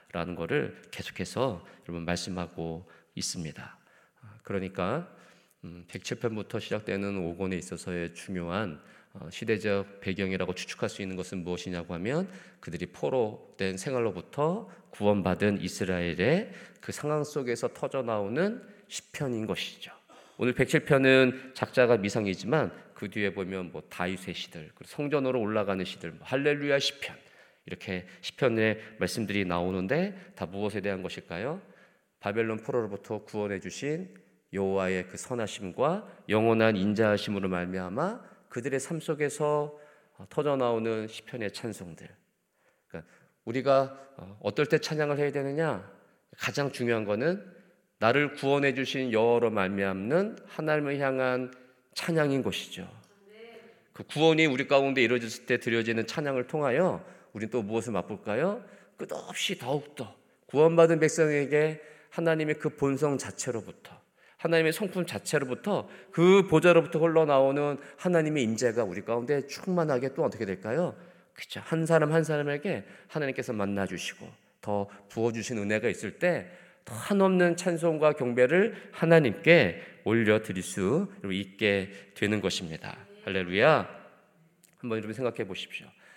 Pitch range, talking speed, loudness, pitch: 100-150 Hz, 310 characters per minute, -29 LUFS, 120 Hz